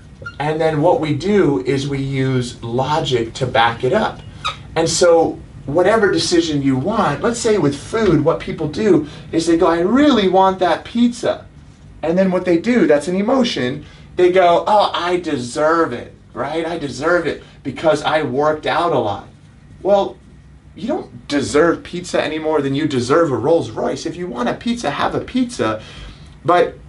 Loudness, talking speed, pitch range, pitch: -17 LUFS, 175 wpm, 135-175 Hz, 155 Hz